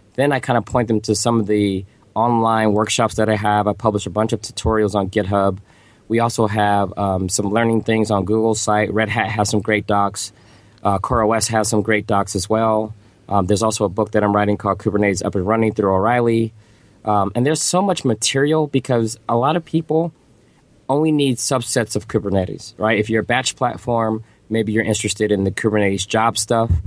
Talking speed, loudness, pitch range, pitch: 205 wpm, -18 LUFS, 105-115 Hz, 110 Hz